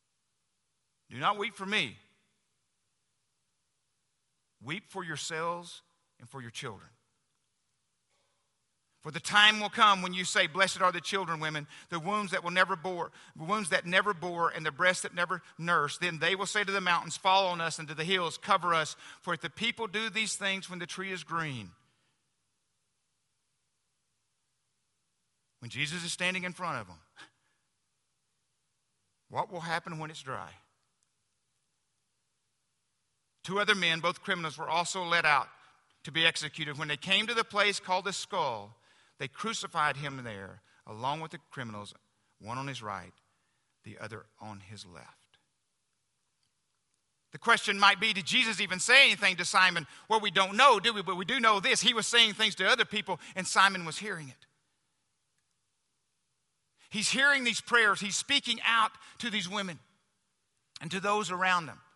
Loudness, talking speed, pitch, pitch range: -28 LUFS, 165 wpm, 175 Hz, 140-200 Hz